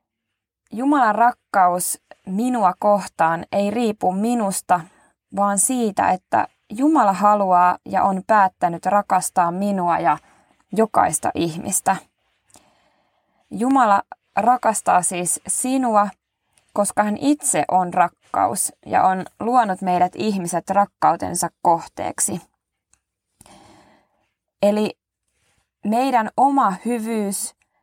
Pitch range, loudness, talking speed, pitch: 180-225 Hz, -19 LUFS, 85 wpm, 200 Hz